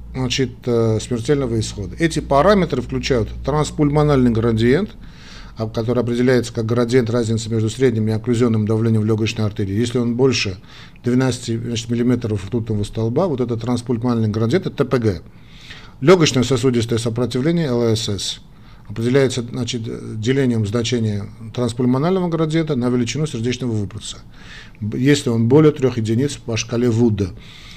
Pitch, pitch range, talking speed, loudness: 120 Hz, 115-130 Hz, 120 wpm, -18 LUFS